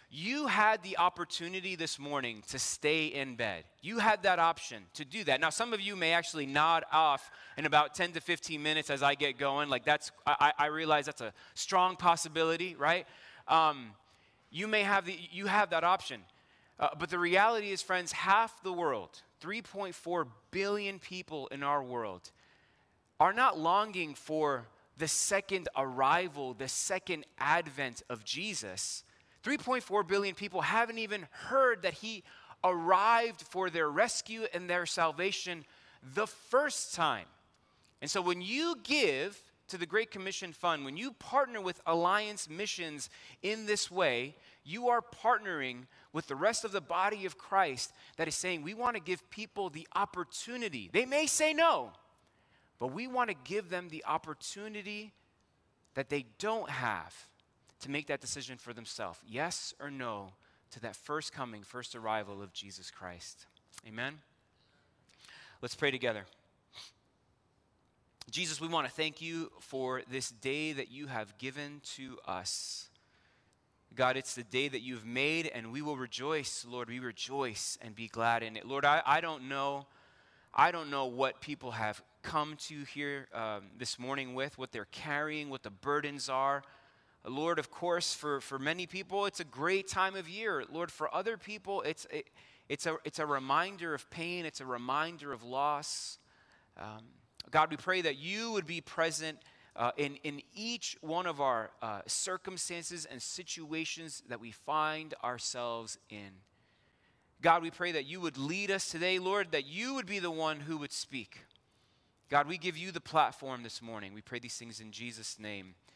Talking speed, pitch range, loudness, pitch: 170 wpm, 130-185 Hz, -34 LUFS, 155 Hz